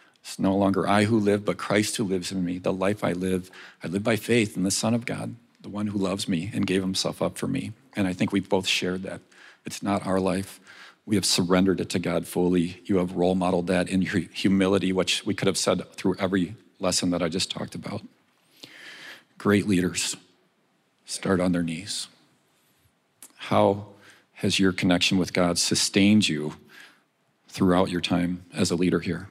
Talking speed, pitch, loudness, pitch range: 195 wpm, 95 Hz, -25 LUFS, 90-100 Hz